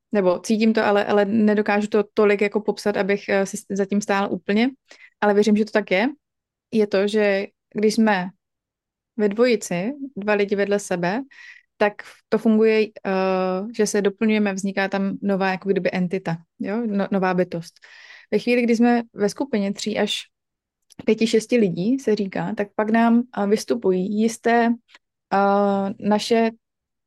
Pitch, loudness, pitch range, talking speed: 210 Hz, -21 LUFS, 195-225 Hz, 155 wpm